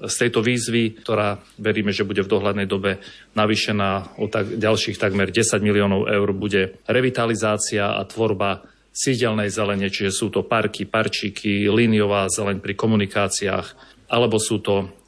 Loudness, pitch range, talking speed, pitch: -21 LUFS, 100-110 Hz, 145 wpm, 105 Hz